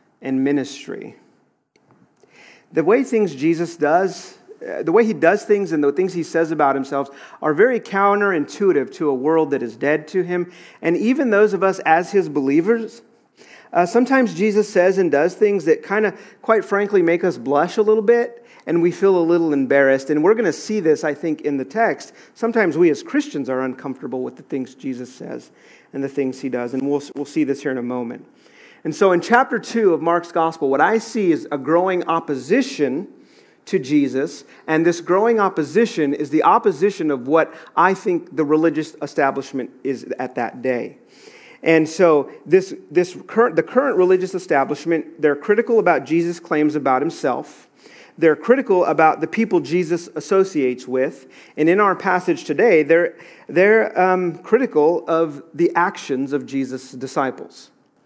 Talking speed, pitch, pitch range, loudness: 180 wpm, 170 Hz, 145-205 Hz, -19 LUFS